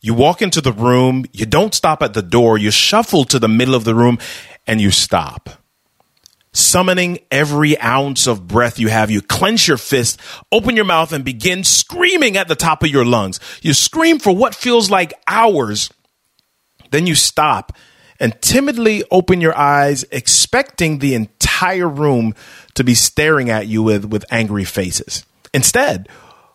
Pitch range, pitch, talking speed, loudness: 115-175 Hz, 140 Hz, 165 wpm, -13 LUFS